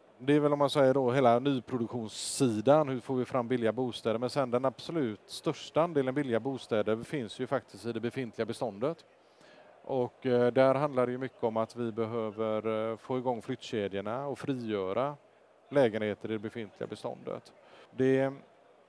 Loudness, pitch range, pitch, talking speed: -31 LUFS, 115-135 Hz, 125 Hz, 160 wpm